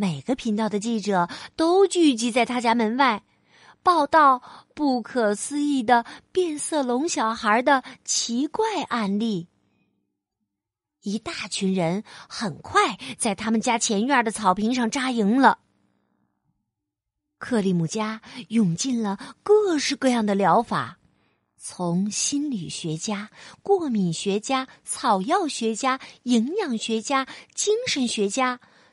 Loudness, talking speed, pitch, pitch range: -23 LUFS, 180 characters per minute, 235 Hz, 205-275 Hz